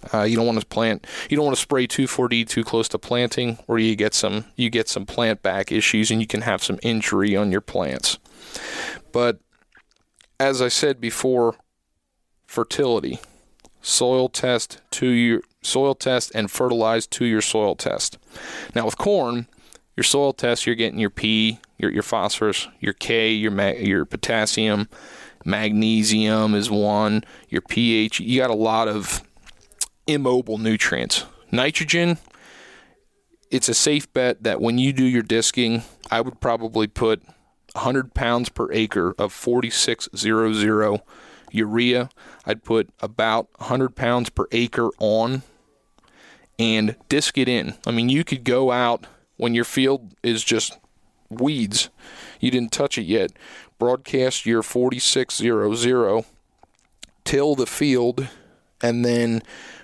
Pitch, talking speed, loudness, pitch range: 115 Hz, 145 wpm, -21 LUFS, 110-125 Hz